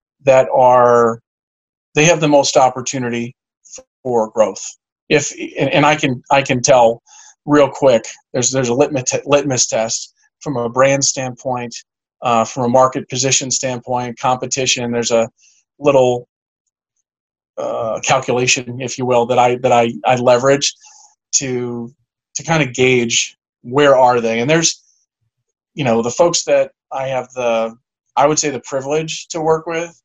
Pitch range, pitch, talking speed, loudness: 120-145 Hz, 130 Hz, 150 wpm, -15 LUFS